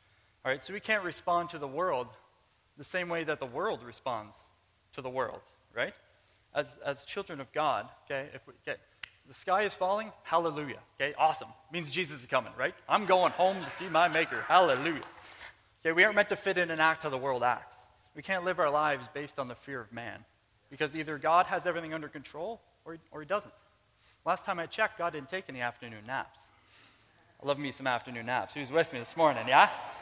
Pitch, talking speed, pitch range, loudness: 150 Hz, 215 wpm, 125-175 Hz, -31 LUFS